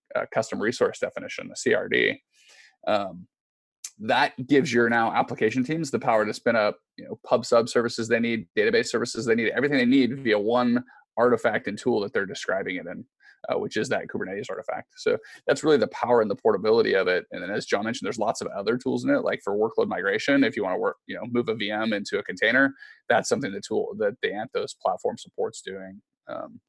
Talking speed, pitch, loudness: 220 wpm, 145 Hz, -25 LUFS